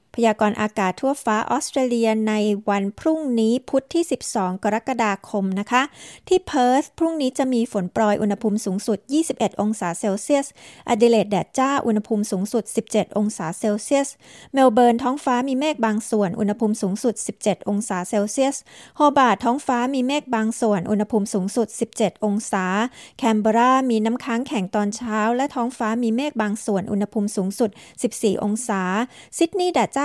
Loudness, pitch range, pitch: -21 LUFS, 210-255 Hz, 225 Hz